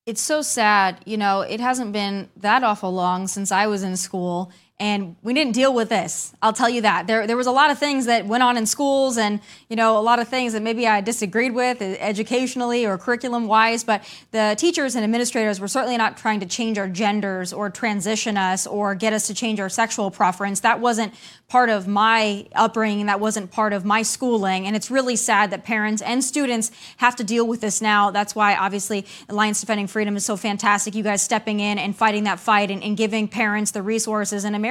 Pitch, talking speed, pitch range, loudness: 215 Hz, 220 wpm, 205-230 Hz, -21 LUFS